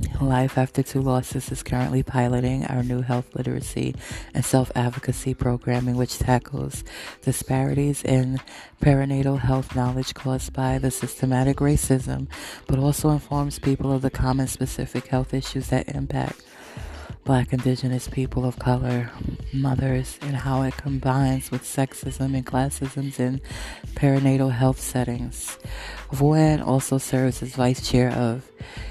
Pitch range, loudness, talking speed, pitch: 125-135 Hz, -24 LUFS, 130 wpm, 130 Hz